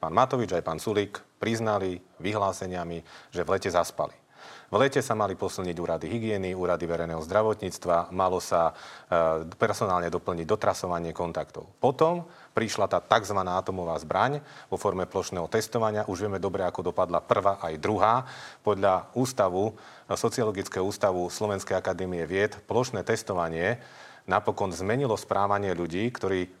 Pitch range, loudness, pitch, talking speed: 85-105 Hz, -28 LUFS, 95 Hz, 135 wpm